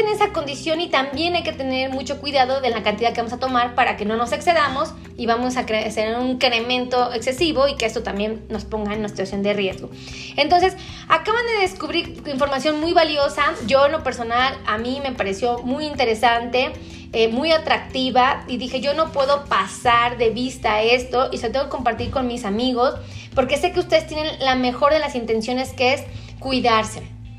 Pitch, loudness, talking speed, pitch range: 255 Hz, -20 LUFS, 200 wpm, 235-290 Hz